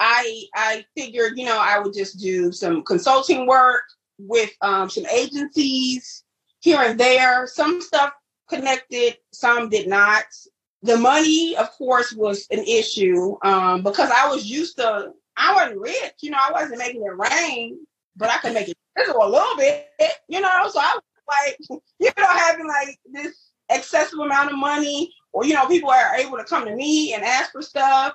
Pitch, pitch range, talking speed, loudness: 270 Hz, 225-310 Hz, 180 wpm, -19 LUFS